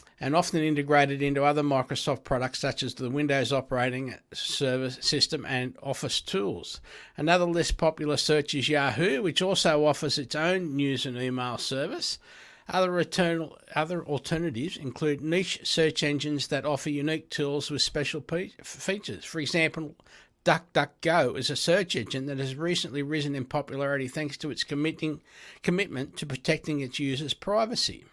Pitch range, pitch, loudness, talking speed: 135-160 Hz, 150 Hz, -28 LUFS, 145 wpm